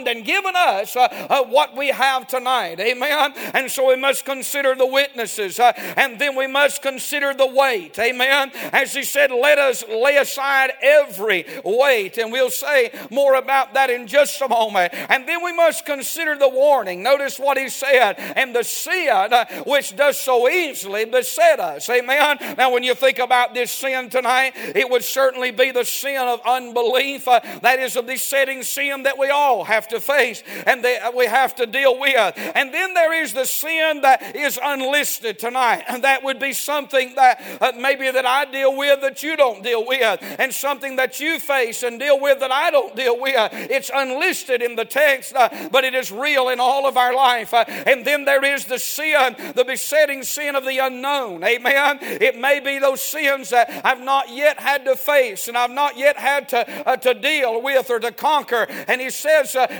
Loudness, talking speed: -18 LUFS, 200 wpm